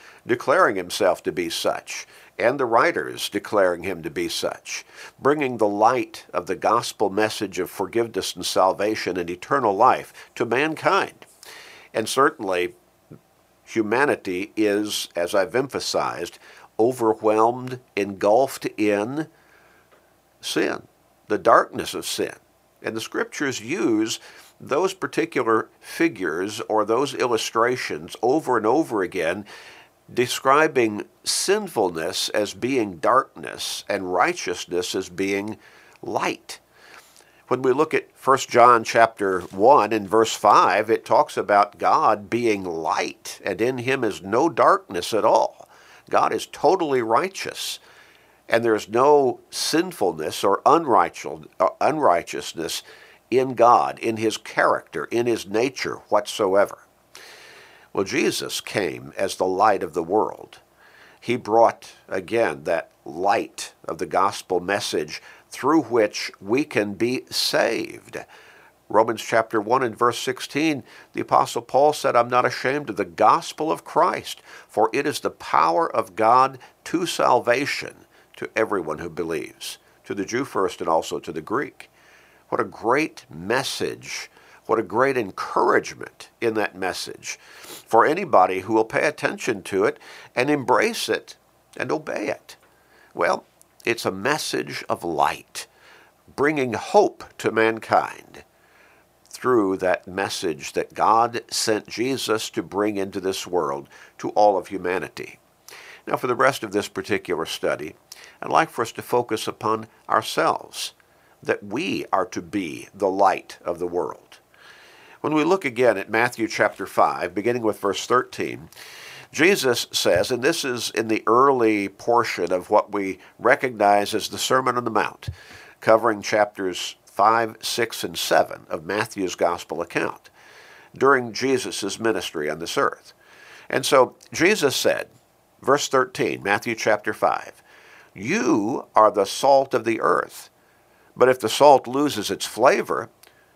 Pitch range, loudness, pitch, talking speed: 105-135 Hz, -22 LUFS, 115 Hz, 135 wpm